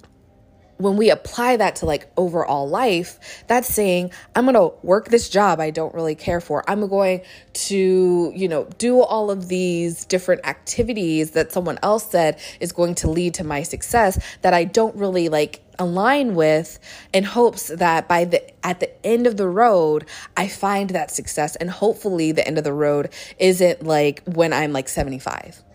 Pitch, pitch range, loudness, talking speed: 180 Hz, 160-205 Hz, -20 LUFS, 180 wpm